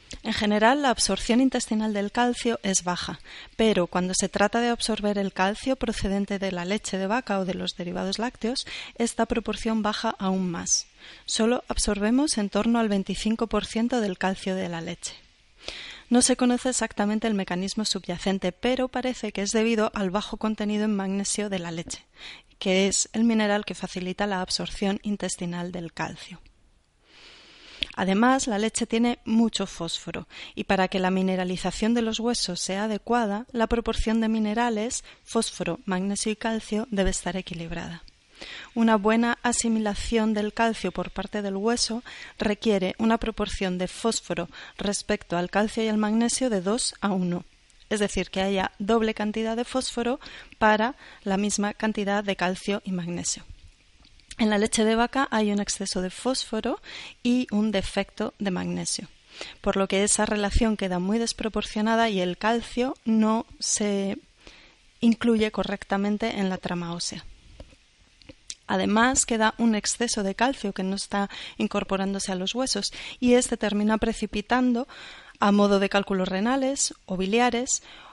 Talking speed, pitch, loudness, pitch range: 155 wpm, 210 Hz, -26 LUFS, 195-230 Hz